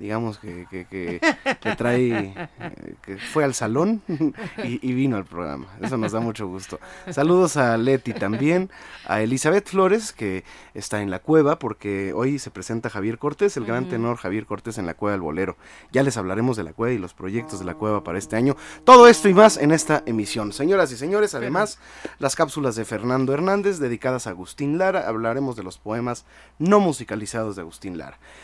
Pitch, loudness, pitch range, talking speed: 115 Hz, -21 LUFS, 105-145 Hz, 195 wpm